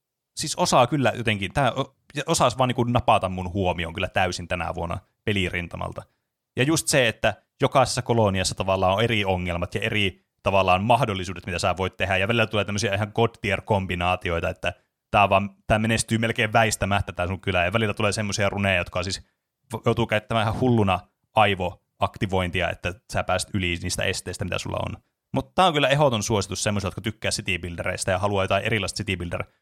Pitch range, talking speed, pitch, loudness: 95-115 Hz, 175 wpm, 100 Hz, -24 LUFS